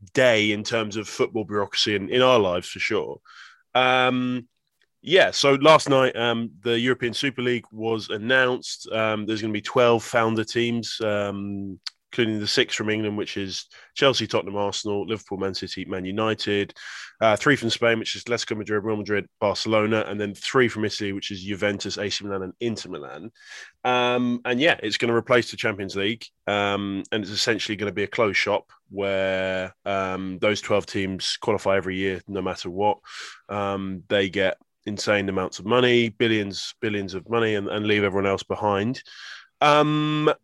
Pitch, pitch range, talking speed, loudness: 105 Hz, 100-120 Hz, 180 wpm, -23 LUFS